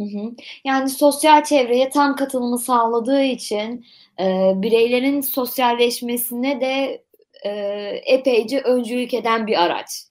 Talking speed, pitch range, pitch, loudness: 90 wpm, 230-270 Hz, 245 Hz, -19 LUFS